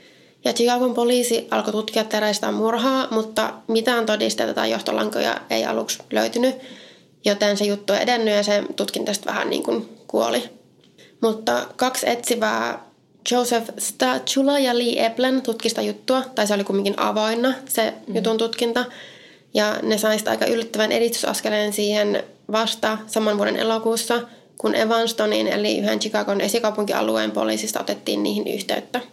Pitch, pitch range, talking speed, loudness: 225 Hz, 210-240 Hz, 140 wpm, -21 LUFS